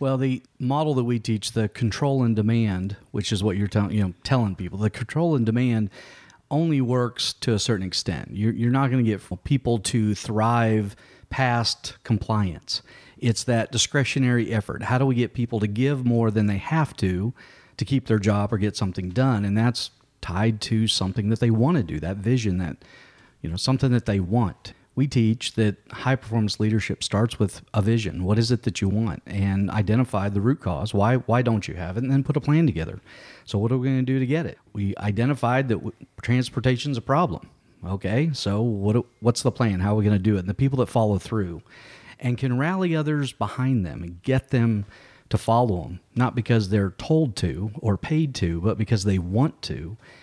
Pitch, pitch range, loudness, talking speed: 115 Hz, 100-125 Hz, -24 LUFS, 210 wpm